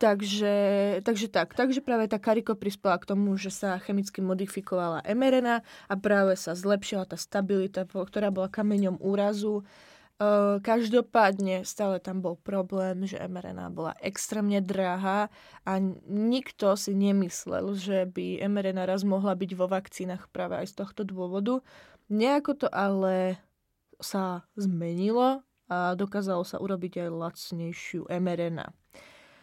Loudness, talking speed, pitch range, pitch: -29 LUFS, 135 wpm, 185-210 Hz, 195 Hz